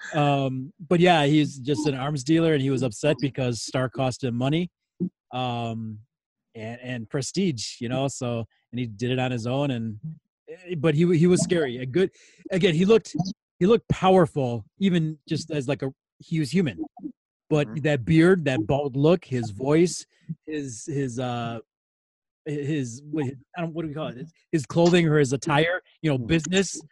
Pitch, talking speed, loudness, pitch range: 150 Hz, 185 wpm, -24 LUFS, 130-170 Hz